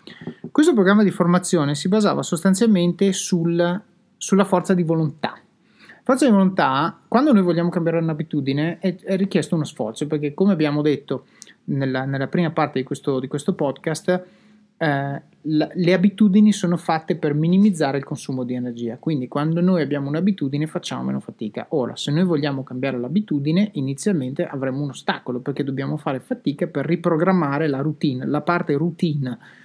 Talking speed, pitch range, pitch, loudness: 160 wpm, 145-185 Hz, 165 Hz, -21 LUFS